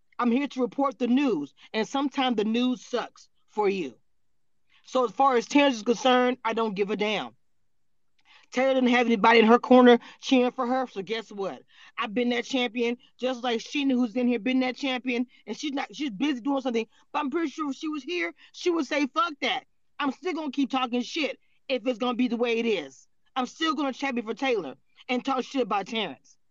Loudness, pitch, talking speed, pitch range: -26 LUFS, 255 Hz, 220 wpm, 240-275 Hz